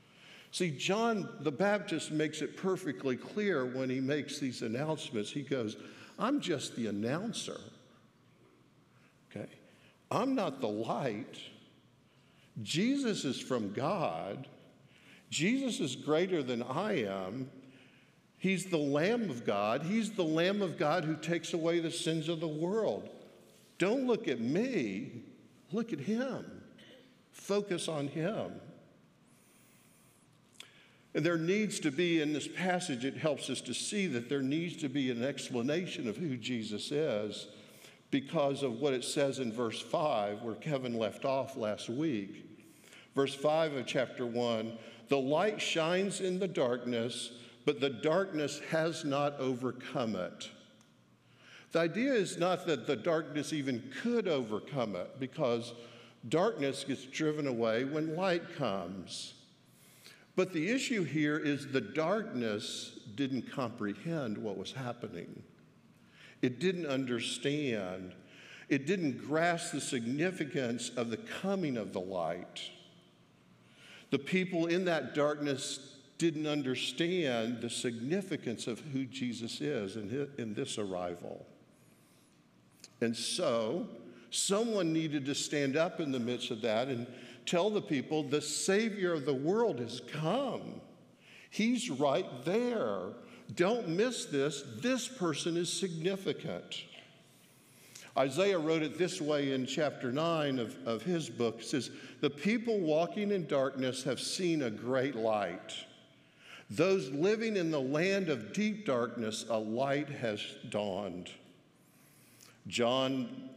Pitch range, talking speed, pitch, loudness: 125-175 Hz, 130 wpm, 145 Hz, -34 LUFS